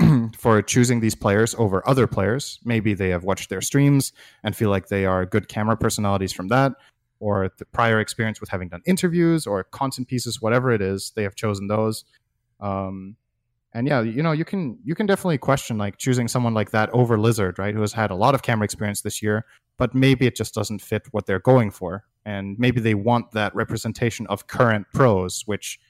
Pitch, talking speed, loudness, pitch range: 110 Hz, 210 wpm, -22 LUFS, 100-125 Hz